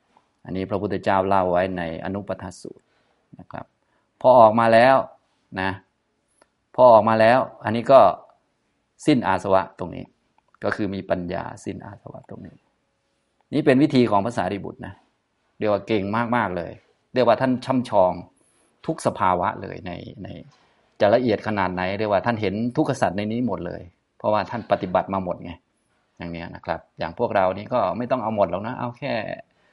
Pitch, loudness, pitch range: 100 Hz, -21 LUFS, 90-110 Hz